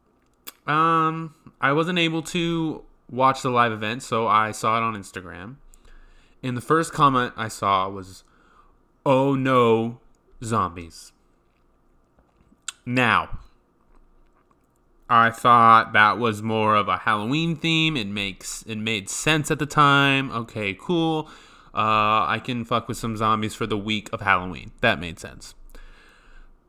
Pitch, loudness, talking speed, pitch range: 115 Hz, -21 LUFS, 135 wpm, 110-140 Hz